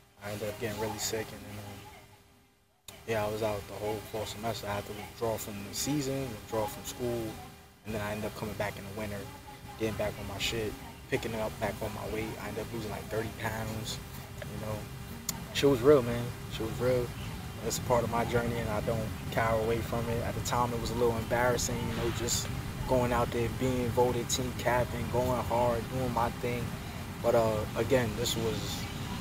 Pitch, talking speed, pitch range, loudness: 115 Hz, 220 wpm, 105-120 Hz, -32 LUFS